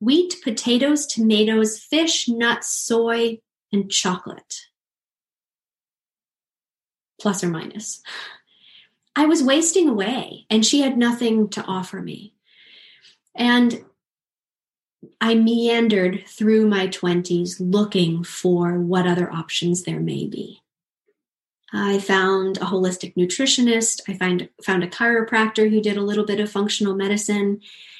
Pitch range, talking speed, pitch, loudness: 190-235 Hz, 115 wpm, 210 Hz, -20 LUFS